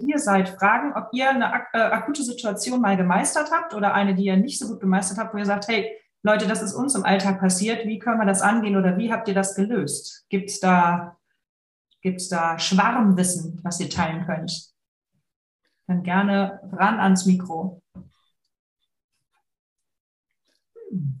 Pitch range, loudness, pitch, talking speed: 185-225 Hz, -22 LUFS, 195 Hz, 165 wpm